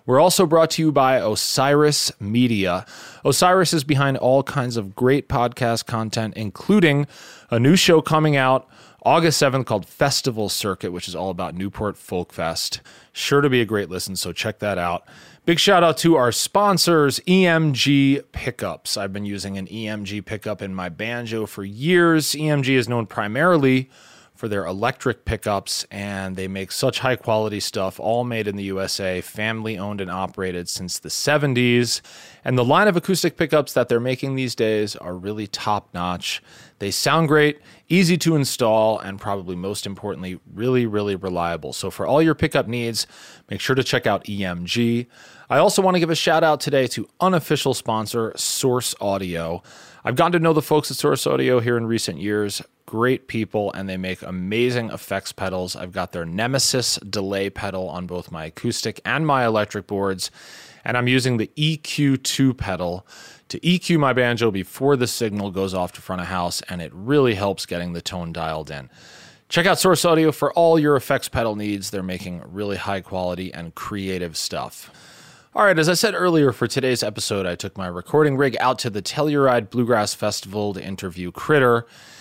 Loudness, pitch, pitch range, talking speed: -21 LUFS, 115 Hz, 100-140 Hz, 180 wpm